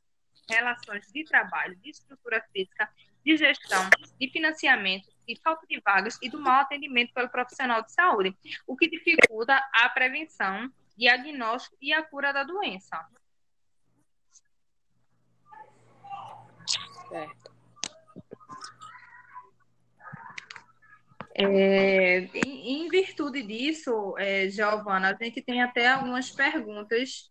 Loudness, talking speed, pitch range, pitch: -25 LUFS, 95 wpm, 220-310 Hz, 255 Hz